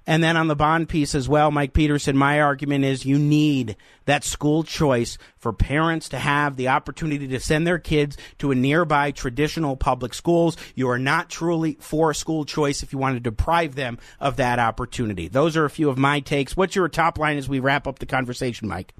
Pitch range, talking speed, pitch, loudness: 130-155 Hz, 215 wpm, 145 Hz, -22 LUFS